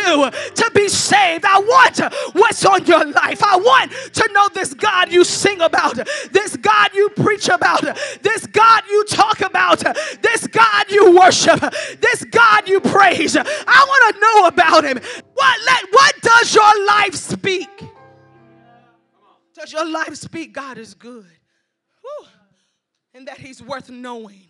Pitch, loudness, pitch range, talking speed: 385 Hz, -13 LUFS, 315-425 Hz, 150 wpm